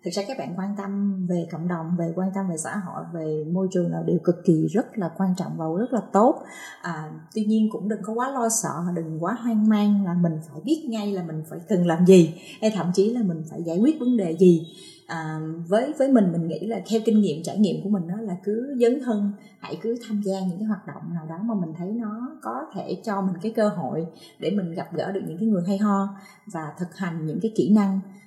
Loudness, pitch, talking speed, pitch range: -24 LUFS, 195 Hz, 260 wpm, 170-215 Hz